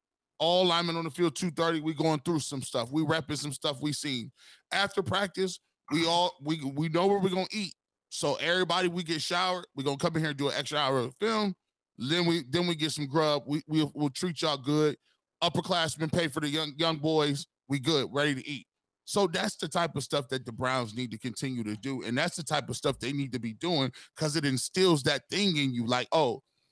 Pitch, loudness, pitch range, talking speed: 155 Hz, -30 LUFS, 140-175 Hz, 245 wpm